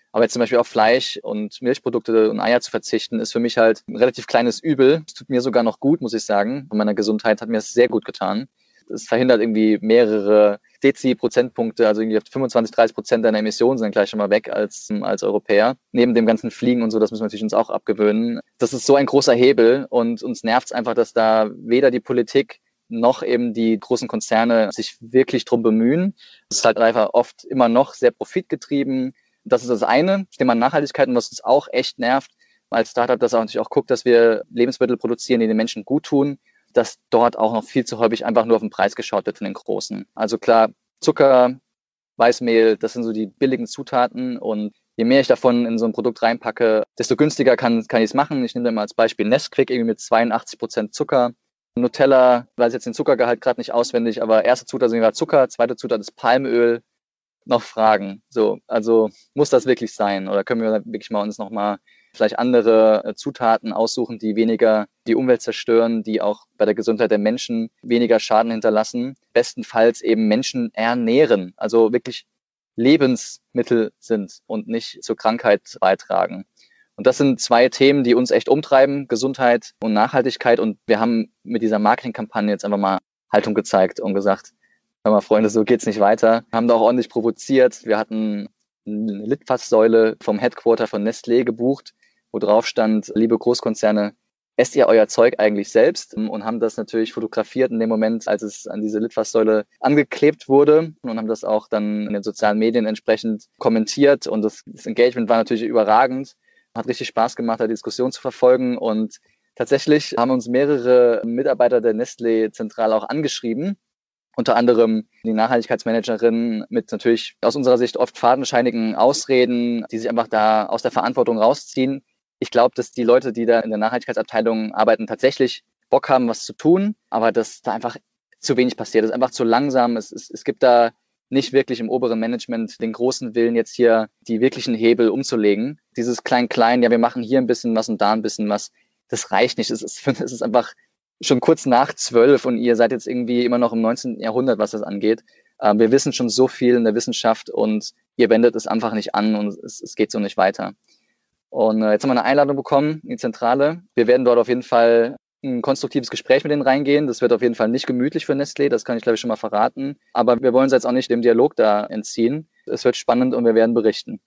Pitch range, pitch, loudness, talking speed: 110-125 Hz, 115 Hz, -19 LUFS, 200 wpm